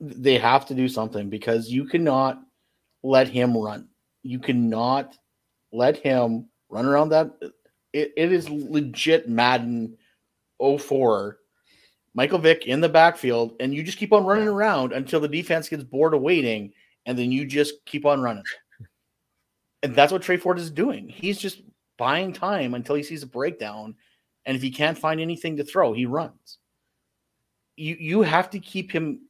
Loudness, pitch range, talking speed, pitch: -23 LUFS, 125-165 Hz, 170 wpm, 145 Hz